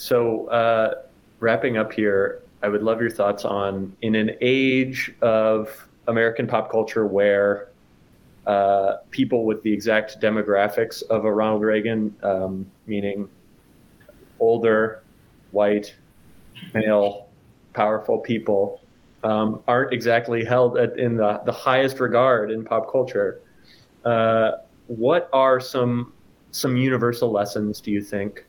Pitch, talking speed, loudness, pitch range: 110 Hz, 125 wpm, -22 LUFS, 105-120 Hz